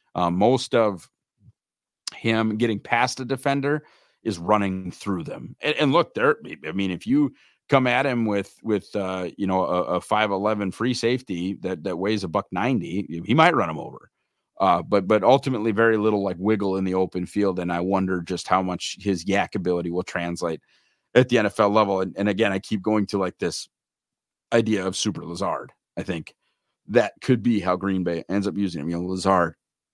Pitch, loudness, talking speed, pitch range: 100 Hz, -23 LUFS, 200 wpm, 90-110 Hz